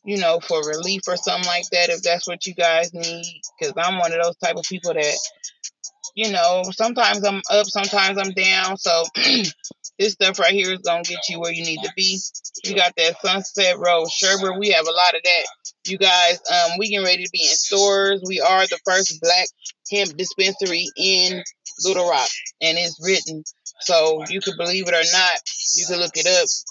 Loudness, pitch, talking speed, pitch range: -18 LUFS, 185 Hz, 205 wpm, 170-200 Hz